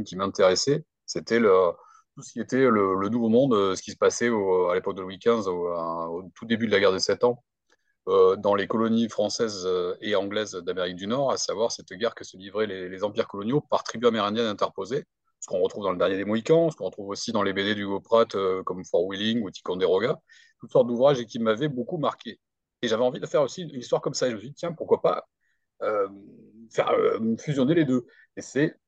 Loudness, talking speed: -25 LUFS, 235 wpm